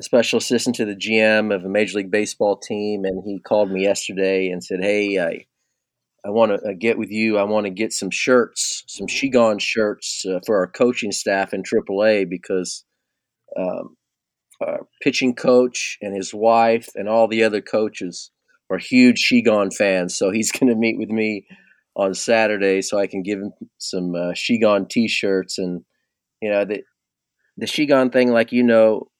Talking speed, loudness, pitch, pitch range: 180 wpm, -19 LUFS, 105 Hz, 100-115 Hz